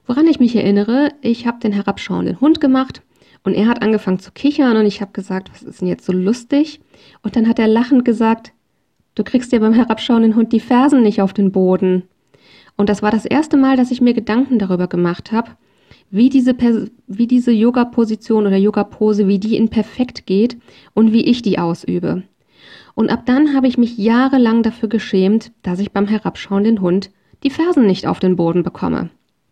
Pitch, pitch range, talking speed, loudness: 225 Hz, 200-245 Hz, 195 wpm, -15 LUFS